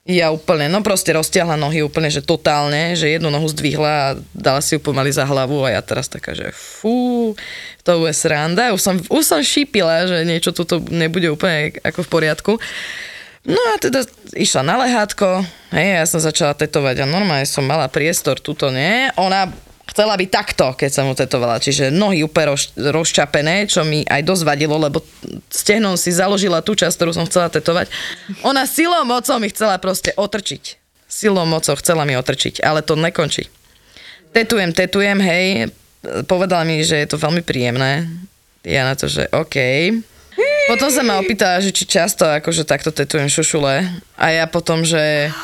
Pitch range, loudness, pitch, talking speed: 150-195 Hz, -16 LUFS, 165 Hz, 175 wpm